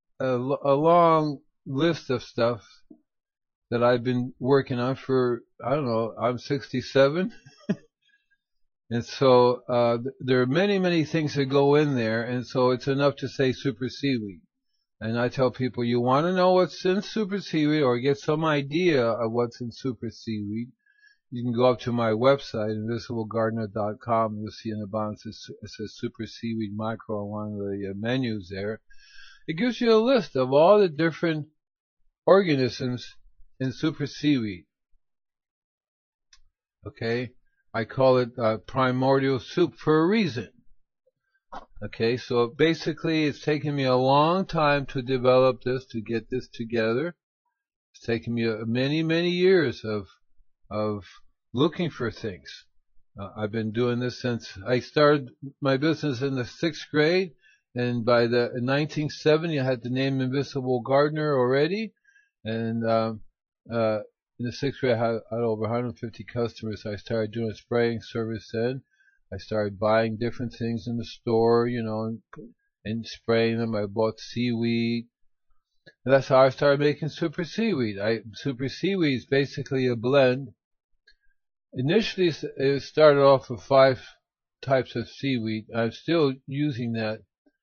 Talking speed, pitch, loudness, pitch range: 155 wpm, 125 Hz, -25 LUFS, 115-150 Hz